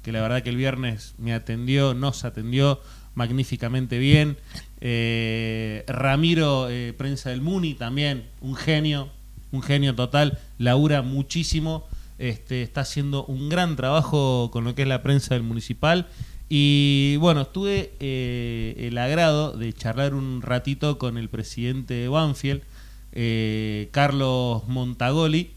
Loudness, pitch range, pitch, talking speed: -24 LUFS, 120-140 Hz, 130 Hz, 135 wpm